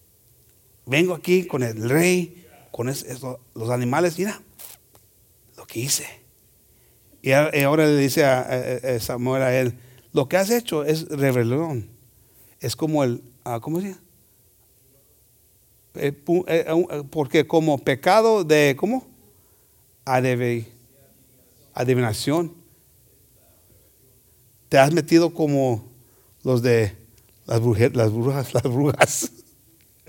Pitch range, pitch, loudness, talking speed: 120-155 Hz, 130 Hz, -21 LUFS, 100 wpm